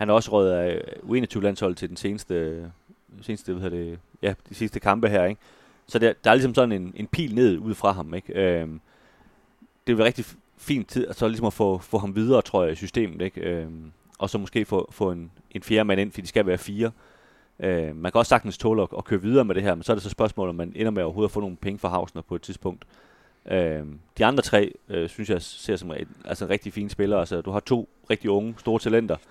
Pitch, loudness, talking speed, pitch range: 100 Hz, -25 LUFS, 260 wpm, 90-110 Hz